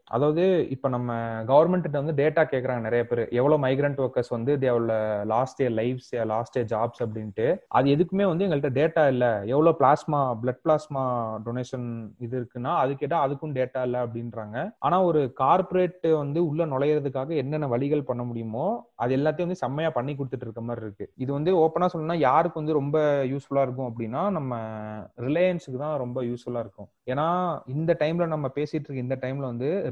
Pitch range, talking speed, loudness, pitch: 120-155 Hz, 125 wpm, -26 LUFS, 135 Hz